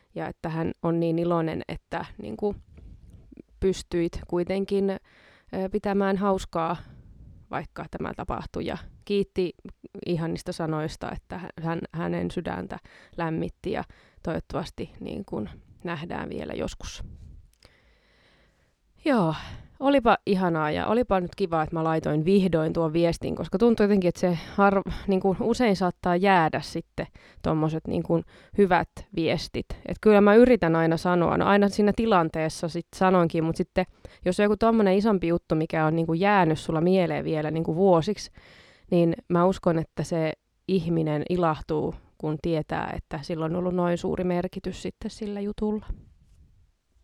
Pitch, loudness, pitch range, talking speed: 175 Hz, -26 LUFS, 160-195 Hz, 140 wpm